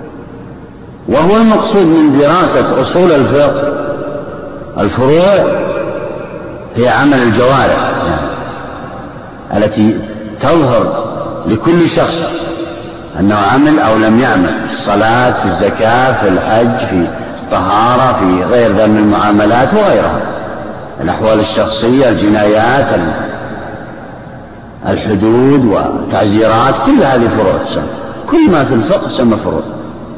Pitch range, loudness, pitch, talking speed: 105-145 Hz, -10 LUFS, 110 Hz, 95 wpm